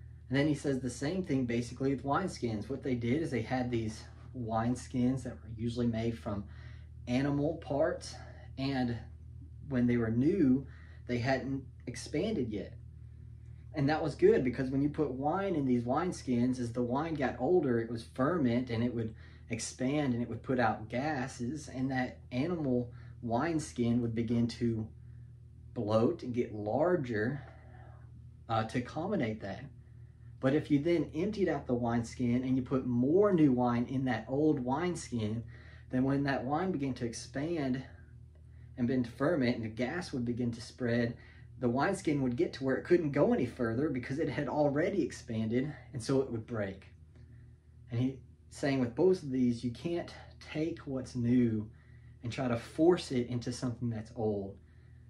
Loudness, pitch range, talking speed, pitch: -33 LUFS, 115-135 Hz, 170 wpm, 120 Hz